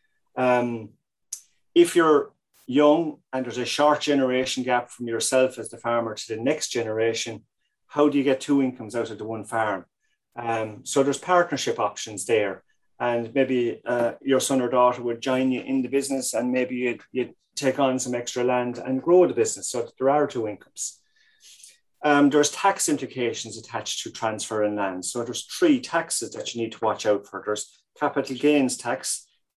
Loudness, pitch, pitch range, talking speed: -24 LUFS, 130 Hz, 115-145 Hz, 180 wpm